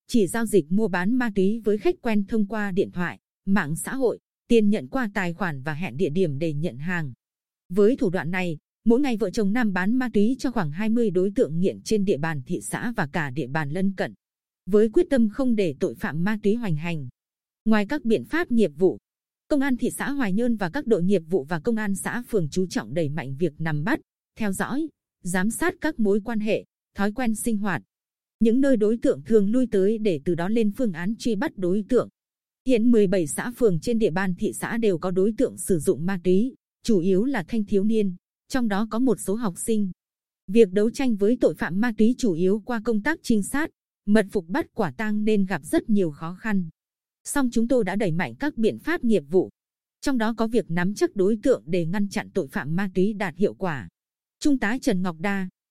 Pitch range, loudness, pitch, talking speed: 185-230 Hz, -24 LUFS, 210 Hz, 235 wpm